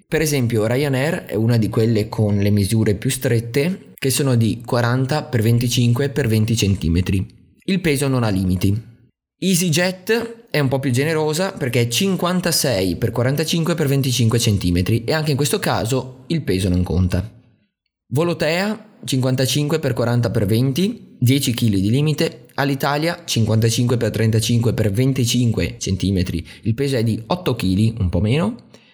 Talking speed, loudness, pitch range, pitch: 155 wpm, -19 LUFS, 110-150 Hz, 125 Hz